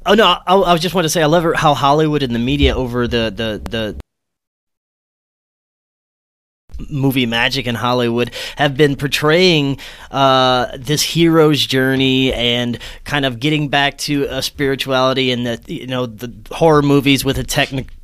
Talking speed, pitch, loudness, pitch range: 165 wpm, 135 Hz, -15 LUFS, 125-150 Hz